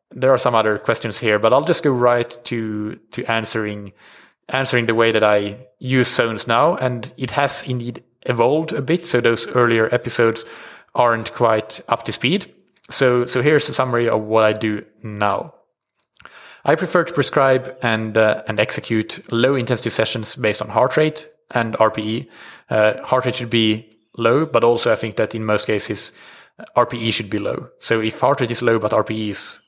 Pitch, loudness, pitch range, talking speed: 115 Hz, -19 LUFS, 110-130 Hz, 185 wpm